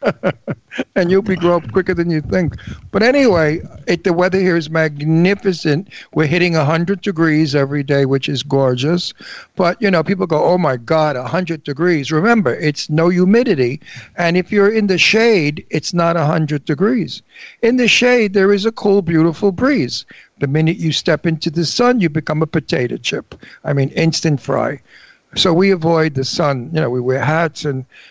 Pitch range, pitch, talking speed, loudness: 155-190 Hz, 165 Hz, 185 wpm, -15 LUFS